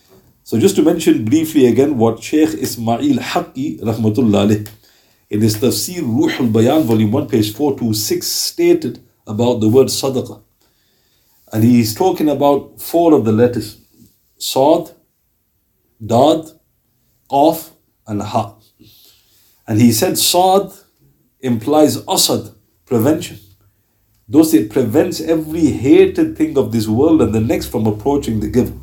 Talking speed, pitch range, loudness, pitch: 130 wpm, 110-150 Hz, -15 LUFS, 120 Hz